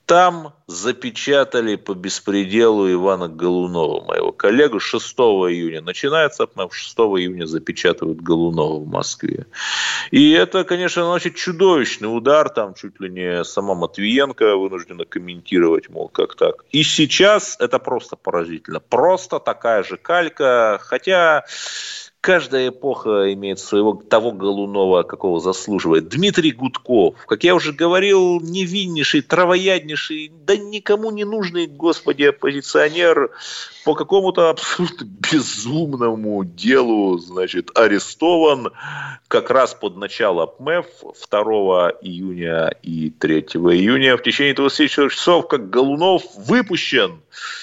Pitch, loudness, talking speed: 150 Hz, -17 LUFS, 115 wpm